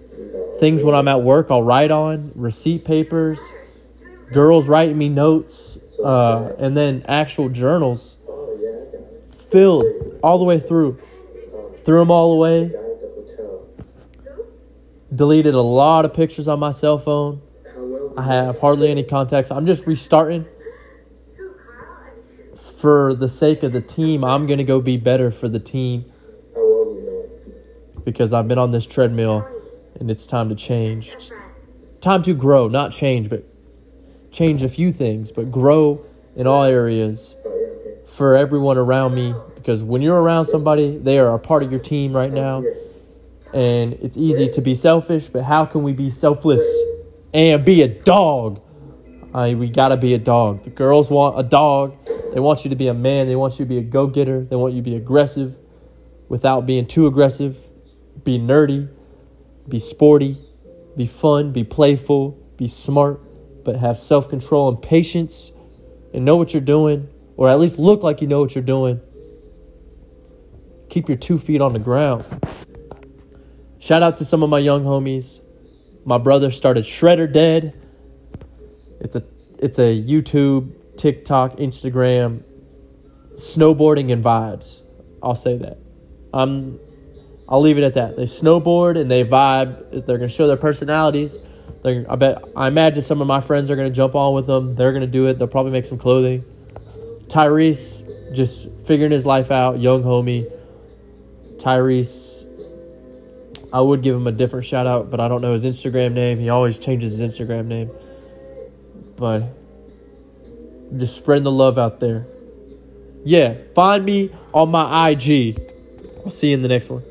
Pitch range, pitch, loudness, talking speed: 120-155 Hz, 135 Hz, -17 LUFS, 160 wpm